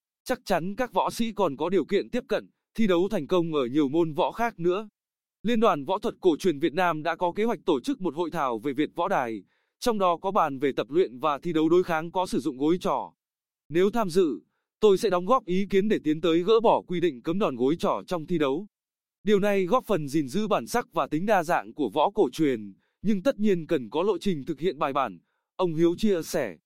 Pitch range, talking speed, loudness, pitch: 165-210 Hz, 255 wpm, -26 LUFS, 180 Hz